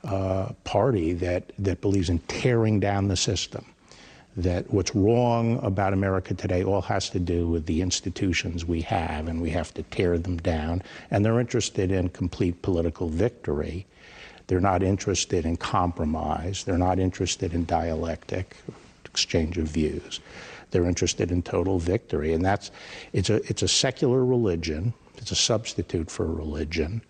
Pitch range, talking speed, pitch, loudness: 85-100 Hz, 155 wpm, 90 Hz, -26 LUFS